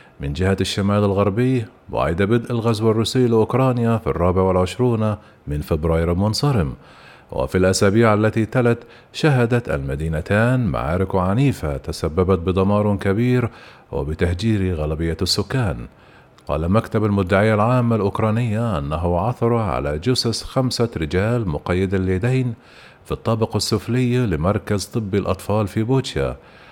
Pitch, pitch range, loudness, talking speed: 105 Hz, 90-120 Hz, -20 LUFS, 110 wpm